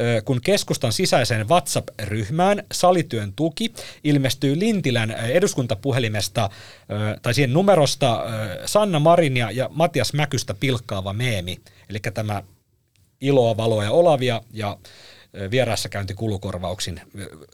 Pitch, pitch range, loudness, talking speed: 120 Hz, 105-145 Hz, -21 LUFS, 95 wpm